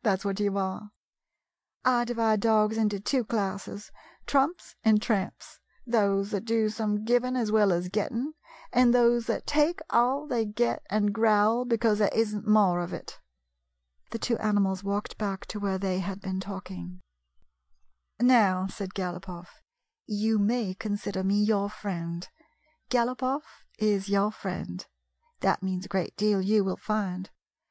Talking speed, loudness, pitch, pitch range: 150 wpm, -28 LUFS, 210 Hz, 190-230 Hz